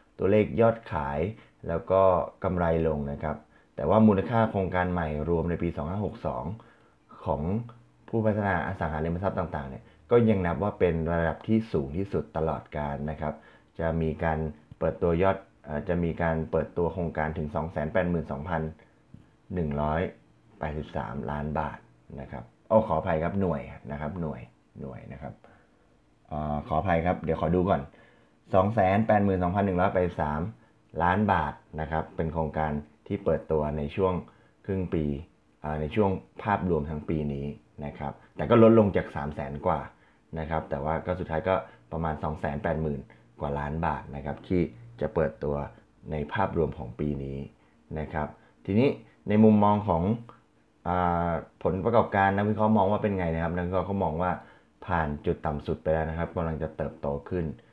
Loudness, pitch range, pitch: -28 LUFS, 75-95 Hz, 80 Hz